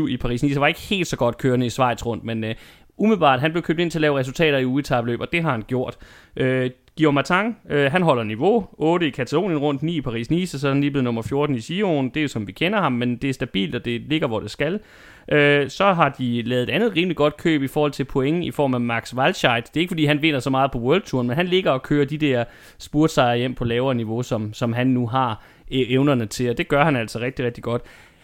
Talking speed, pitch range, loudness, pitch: 270 wpm, 120-155 Hz, -21 LUFS, 135 Hz